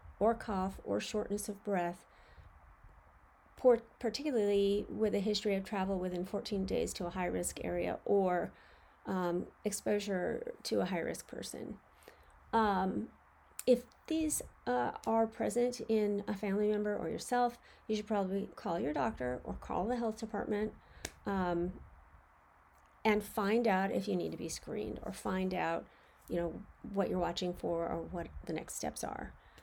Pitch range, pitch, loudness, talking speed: 175-215 Hz, 200 Hz, -36 LUFS, 150 wpm